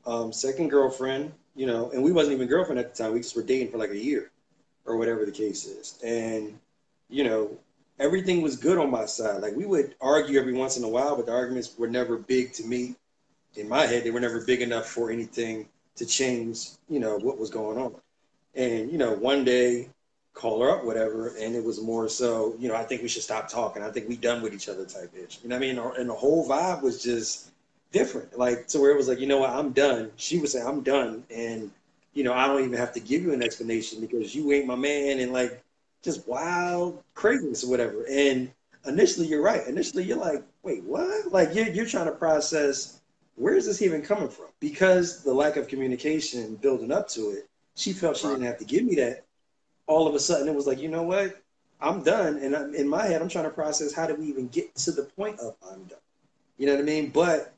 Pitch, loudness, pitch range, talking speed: 130 Hz, -27 LUFS, 120-155 Hz, 240 wpm